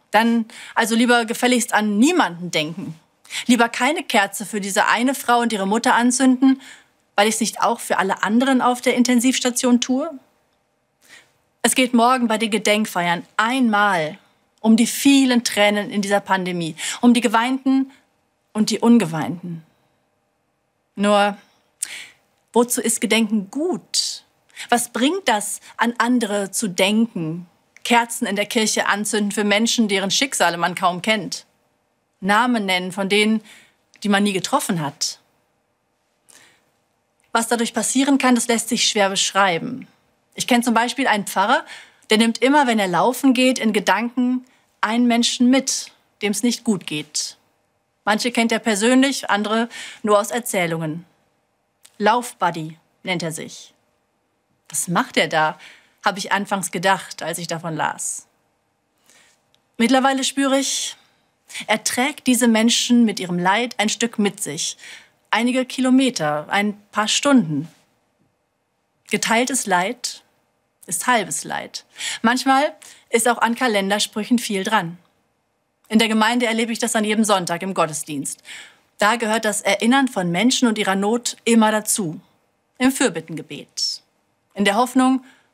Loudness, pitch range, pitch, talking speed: -19 LUFS, 195-245 Hz, 220 Hz, 140 wpm